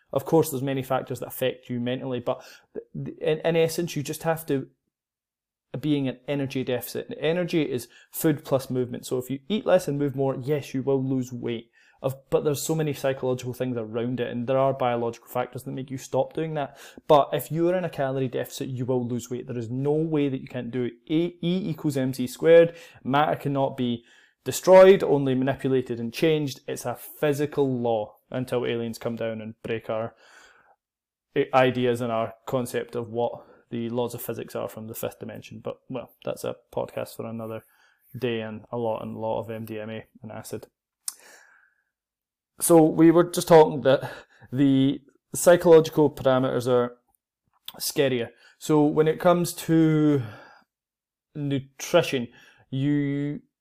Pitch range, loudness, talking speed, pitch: 120-150 Hz, -25 LUFS, 175 wpm, 135 Hz